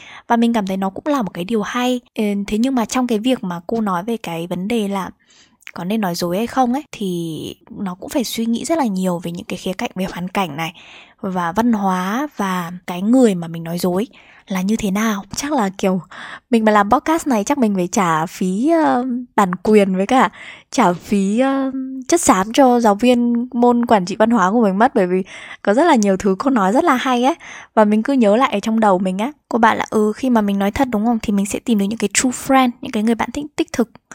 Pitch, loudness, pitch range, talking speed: 220 Hz, -17 LUFS, 190-250 Hz, 260 wpm